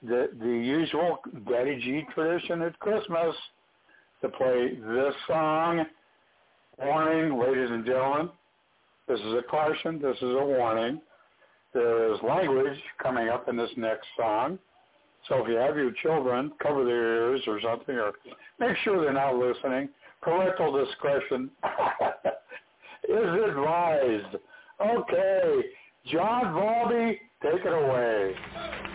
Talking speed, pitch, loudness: 125 wpm, 160 Hz, -28 LUFS